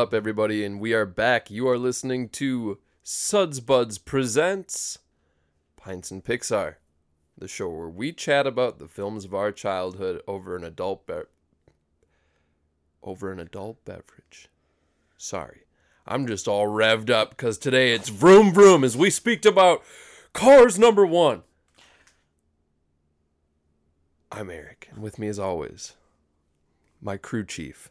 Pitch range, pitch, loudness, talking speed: 75-130 Hz, 100 Hz, -21 LUFS, 135 wpm